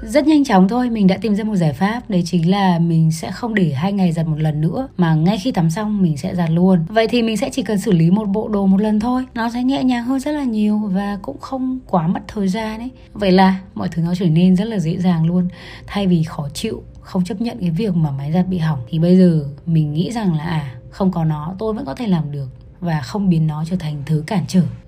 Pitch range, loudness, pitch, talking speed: 165-220 Hz, -18 LUFS, 185 Hz, 275 wpm